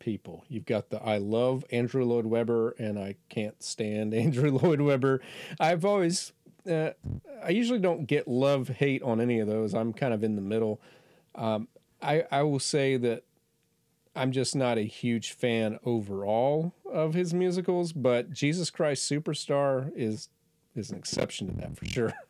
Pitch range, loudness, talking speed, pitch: 115-155 Hz, -29 LUFS, 170 wpm, 130 Hz